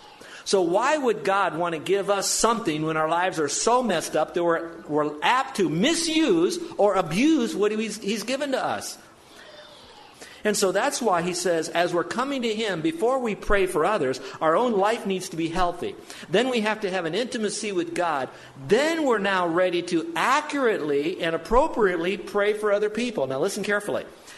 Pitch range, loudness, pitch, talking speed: 175-235 Hz, -24 LUFS, 200 Hz, 190 wpm